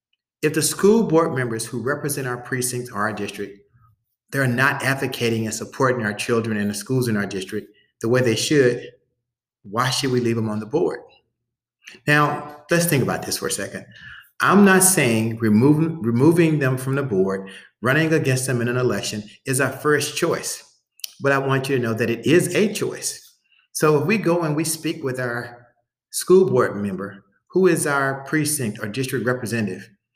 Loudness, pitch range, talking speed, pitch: -20 LUFS, 115-150 Hz, 185 wpm, 130 Hz